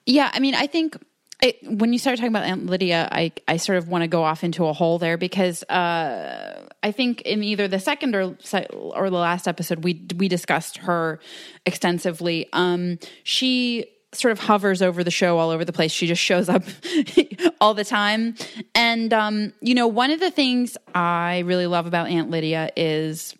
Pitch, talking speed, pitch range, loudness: 185 Hz, 195 wpm, 175-240 Hz, -22 LUFS